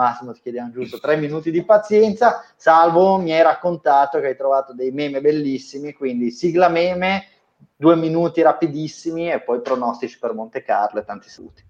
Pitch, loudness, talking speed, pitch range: 155 Hz, -18 LUFS, 170 wpm, 130-175 Hz